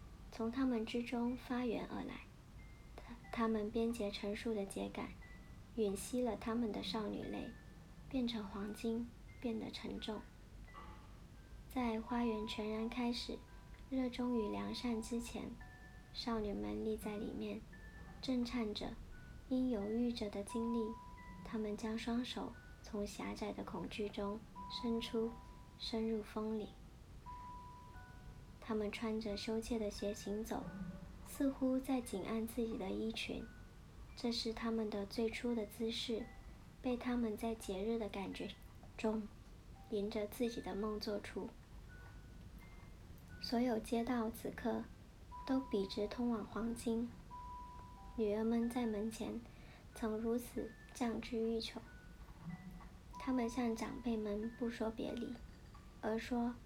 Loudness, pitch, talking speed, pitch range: -42 LUFS, 225 Hz, 180 characters per minute, 210-240 Hz